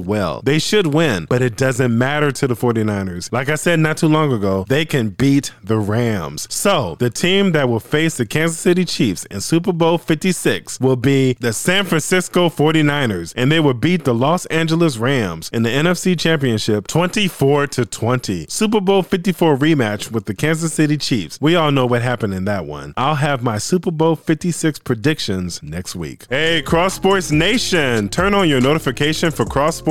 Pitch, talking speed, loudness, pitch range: 145 Hz, 190 wpm, -17 LUFS, 120-165 Hz